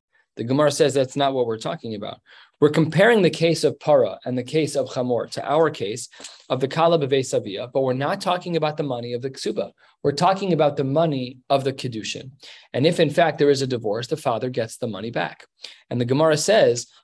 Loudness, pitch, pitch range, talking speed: -22 LUFS, 140 Hz, 125-160 Hz, 225 wpm